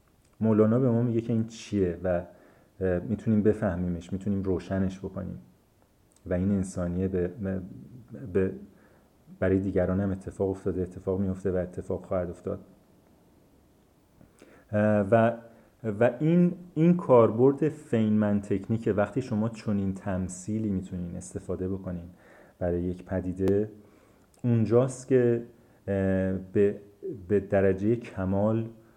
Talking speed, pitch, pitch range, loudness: 110 wpm, 100 Hz, 95-110 Hz, -28 LUFS